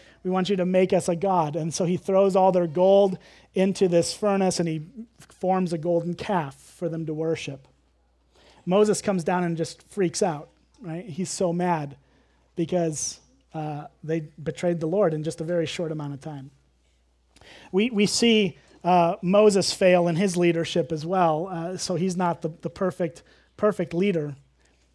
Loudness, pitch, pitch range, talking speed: -24 LUFS, 175 Hz, 160-185 Hz, 175 wpm